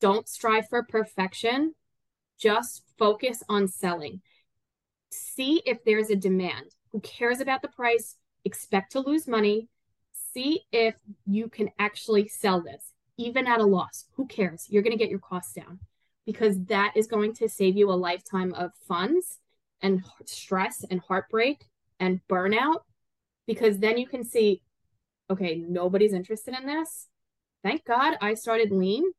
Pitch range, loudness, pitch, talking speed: 190-235 Hz, -26 LUFS, 215 Hz, 150 wpm